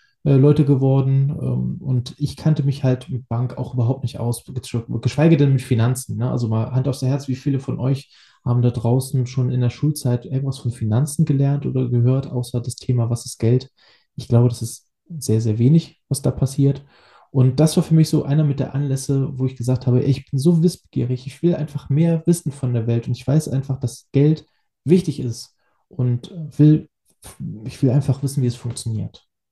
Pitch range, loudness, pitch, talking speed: 120-145 Hz, -20 LUFS, 130 Hz, 200 wpm